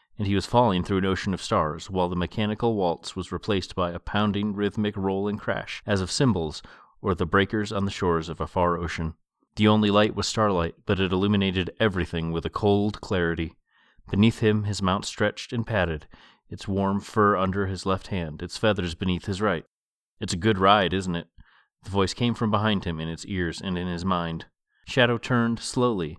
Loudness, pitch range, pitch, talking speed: -25 LUFS, 90-105 Hz, 95 Hz, 205 wpm